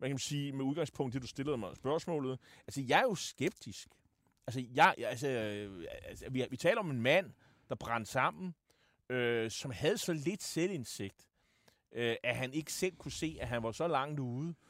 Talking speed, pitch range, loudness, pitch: 190 wpm, 120-155 Hz, -36 LUFS, 130 Hz